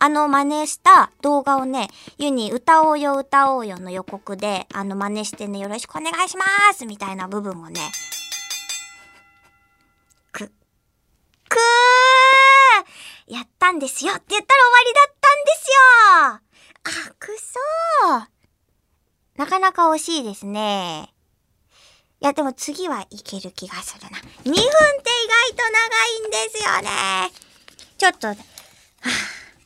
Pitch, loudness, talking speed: 275 Hz, -16 LUFS, 250 characters per minute